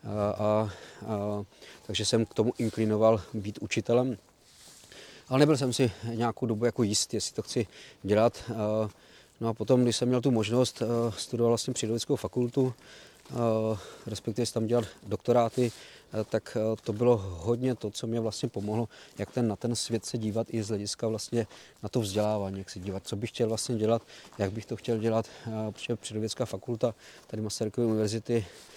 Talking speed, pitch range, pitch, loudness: 180 wpm, 105-120 Hz, 115 Hz, -30 LUFS